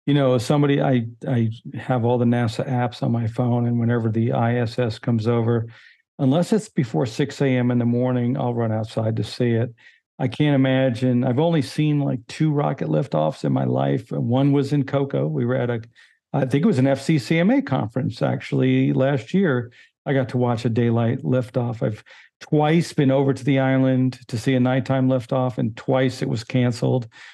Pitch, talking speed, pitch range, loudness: 130 Hz, 195 wpm, 120-135 Hz, -21 LUFS